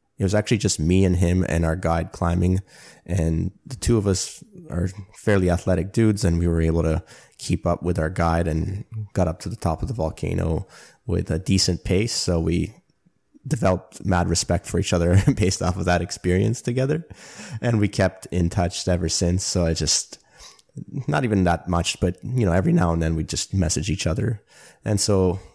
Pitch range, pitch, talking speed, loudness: 85-100 Hz, 90 Hz, 200 wpm, -23 LUFS